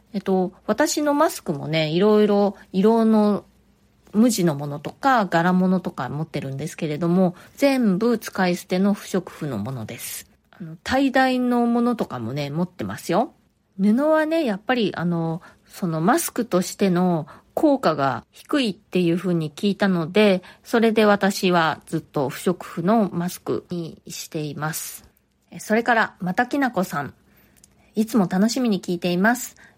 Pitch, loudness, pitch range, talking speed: 190 Hz, -22 LUFS, 170-225 Hz, 300 characters per minute